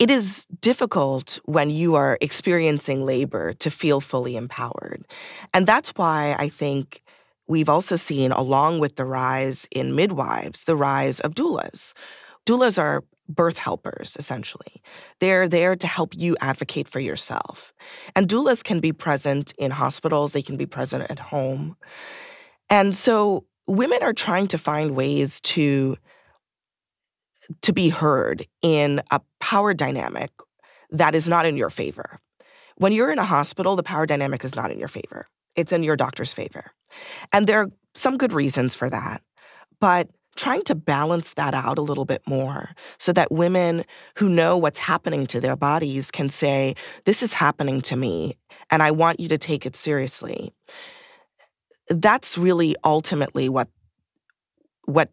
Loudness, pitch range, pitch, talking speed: -22 LUFS, 140-185 Hz, 155 Hz, 155 wpm